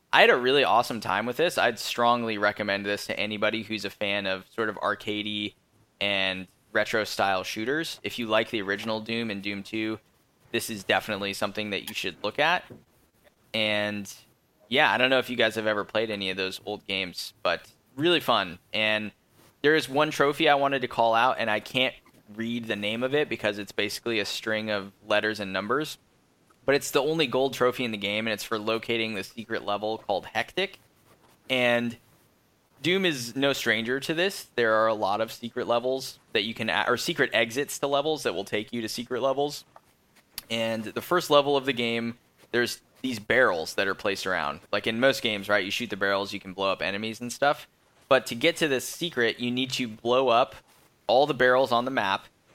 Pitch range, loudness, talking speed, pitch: 105-130 Hz, -26 LUFS, 210 wpm, 115 Hz